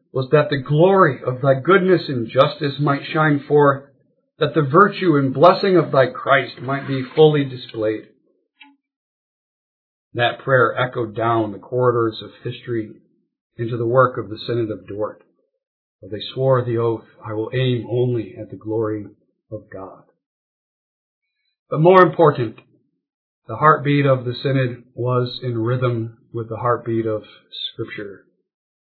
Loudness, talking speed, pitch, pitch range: -18 LUFS, 145 wpm, 125 Hz, 115-150 Hz